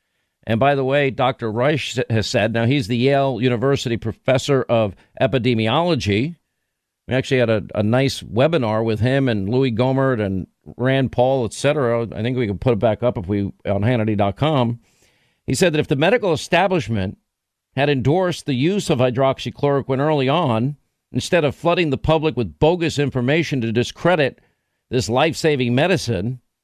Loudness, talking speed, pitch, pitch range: -19 LUFS, 160 wpm, 125 Hz, 115-140 Hz